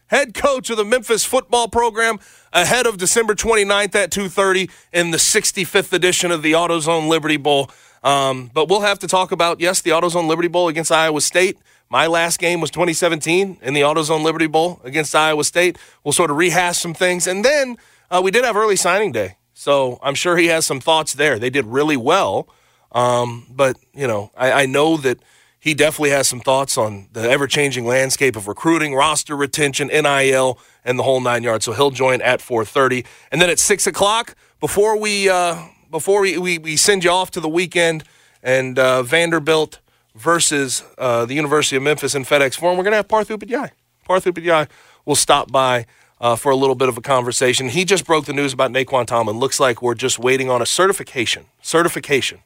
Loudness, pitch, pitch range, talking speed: -17 LUFS, 160 Hz, 135-180 Hz, 200 wpm